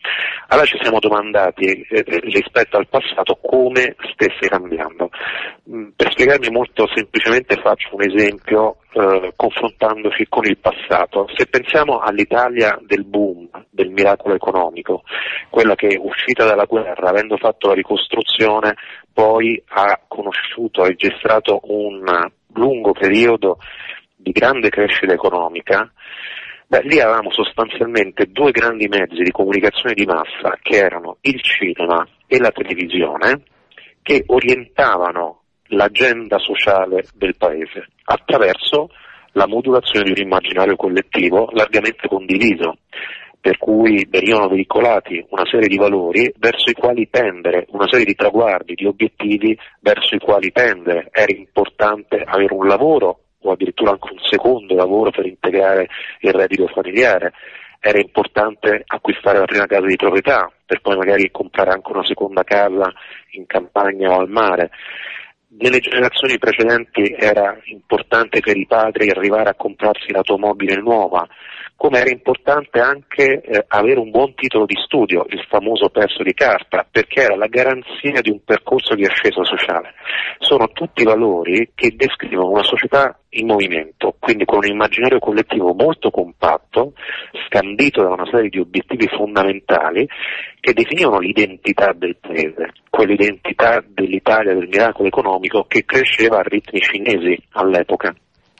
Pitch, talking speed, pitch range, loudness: 105 Hz, 135 wpm, 95-115 Hz, -15 LUFS